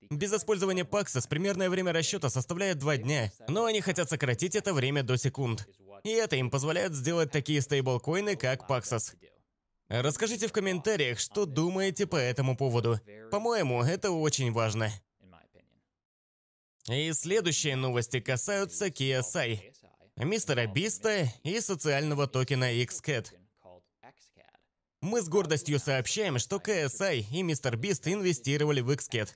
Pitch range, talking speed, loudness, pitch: 125-185 Hz, 125 wpm, -29 LUFS, 145 Hz